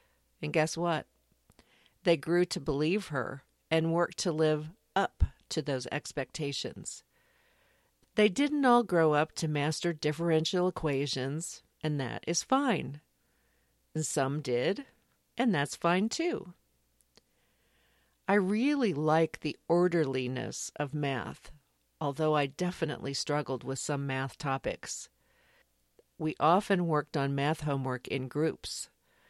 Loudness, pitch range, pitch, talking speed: -31 LUFS, 135-170 Hz, 150 Hz, 120 wpm